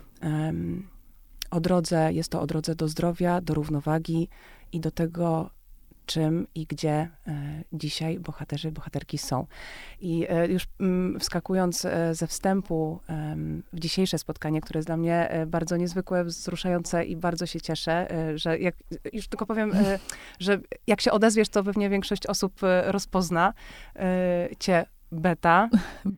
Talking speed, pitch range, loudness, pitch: 130 wpm, 160-185 Hz, -27 LUFS, 170 Hz